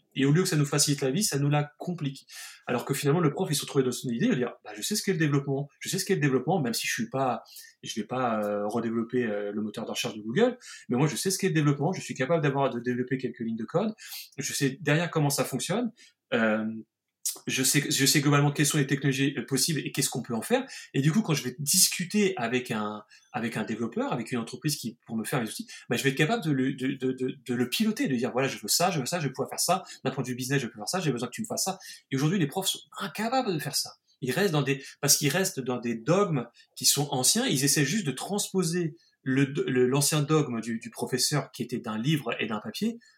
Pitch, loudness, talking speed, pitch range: 140 Hz, -27 LUFS, 280 wpm, 125-175 Hz